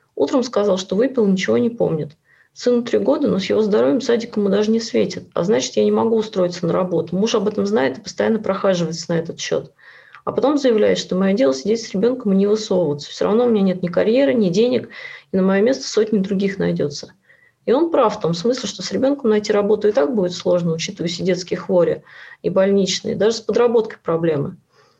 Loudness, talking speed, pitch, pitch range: -18 LUFS, 215 wpm, 205 Hz, 185-225 Hz